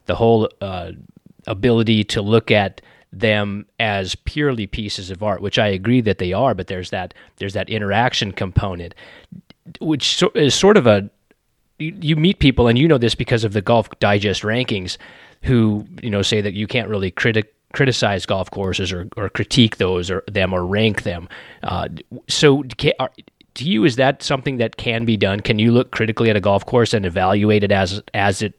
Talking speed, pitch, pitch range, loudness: 195 wpm, 110 Hz, 100-120 Hz, -18 LUFS